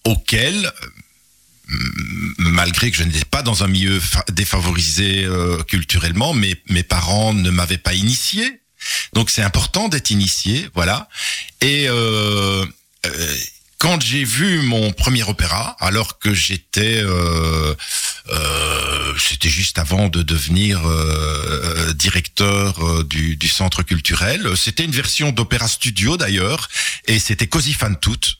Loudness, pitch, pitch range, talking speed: -17 LUFS, 95 Hz, 85-110 Hz, 135 wpm